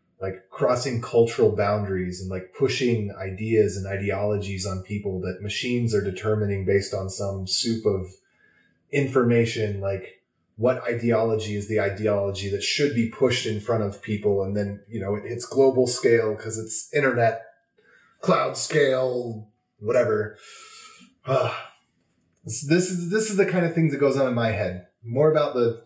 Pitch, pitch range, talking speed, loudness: 110 Hz, 100-125 Hz, 160 wpm, -24 LUFS